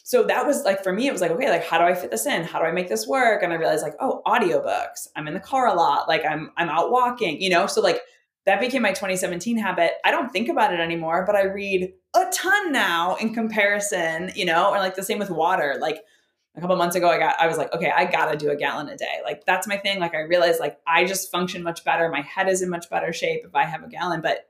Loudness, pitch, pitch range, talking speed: -22 LUFS, 185 Hz, 170-225 Hz, 285 wpm